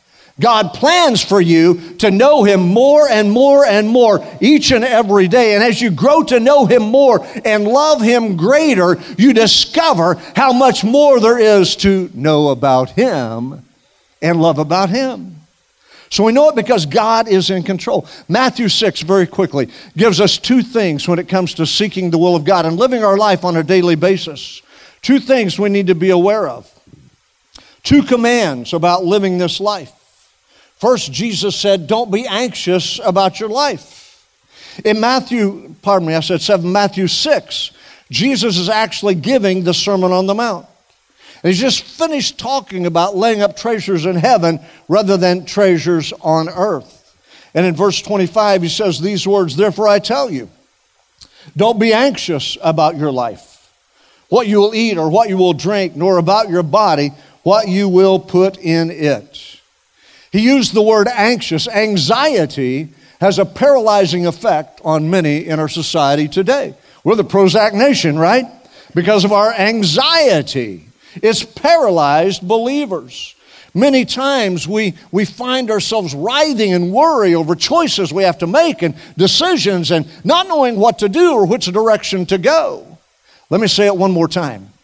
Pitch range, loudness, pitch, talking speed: 175-235 Hz, -13 LUFS, 200 Hz, 165 wpm